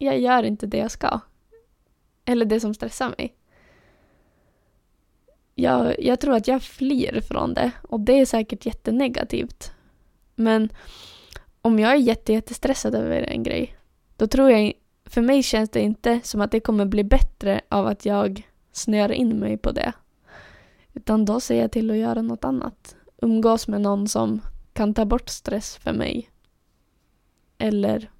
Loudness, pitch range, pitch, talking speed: -22 LUFS, 210-250 Hz, 225 Hz, 160 wpm